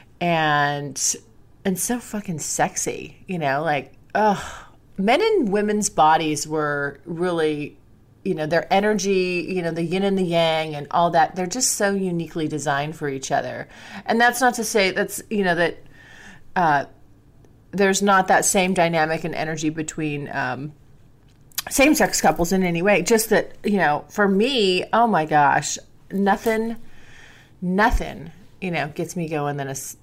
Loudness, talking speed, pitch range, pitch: -21 LUFS, 160 wpm, 145-200 Hz, 170 Hz